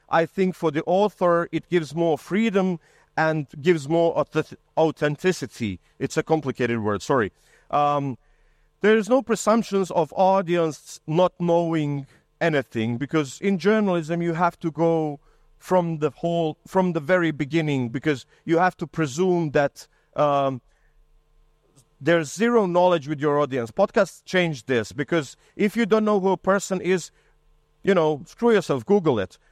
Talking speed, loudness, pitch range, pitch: 150 wpm, -23 LUFS, 150-185 Hz, 165 Hz